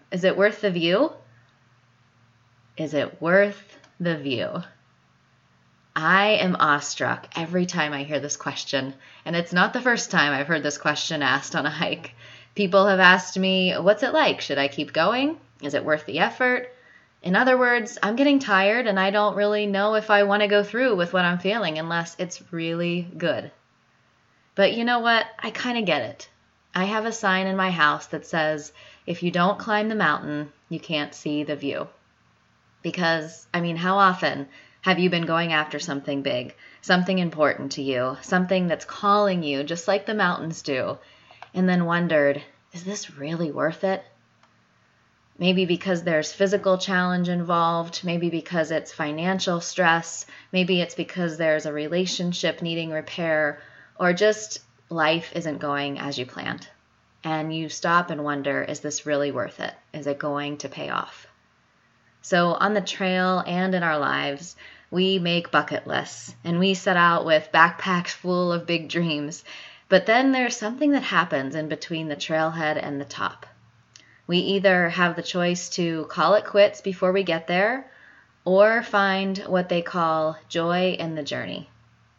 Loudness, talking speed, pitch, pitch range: -23 LUFS, 170 wpm, 170 Hz, 150-190 Hz